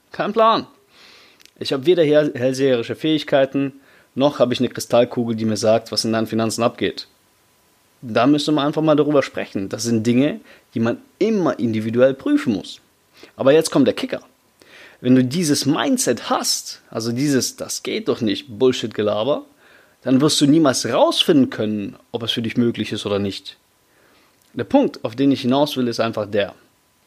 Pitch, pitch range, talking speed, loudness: 130 Hz, 115-150 Hz, 170 wpm, -19 LUFS